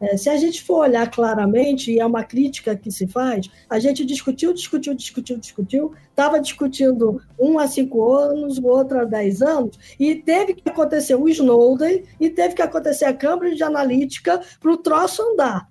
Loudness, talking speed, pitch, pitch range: -19 LUFS, 185 wpm, 275 Hz, 235-310 Hz